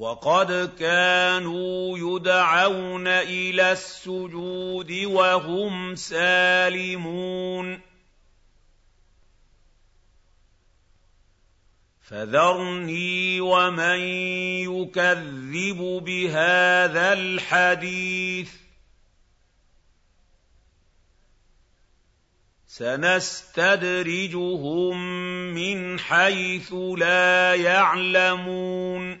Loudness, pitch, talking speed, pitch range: -22 LUFS, 180 Hz, 35 wpm, 115-185 Hz